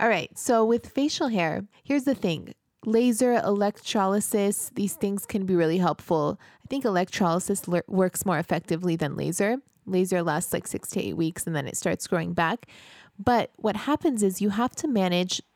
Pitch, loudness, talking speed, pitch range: 200 Hz, -26 LUFS, 180 wpm, 175-230 Hz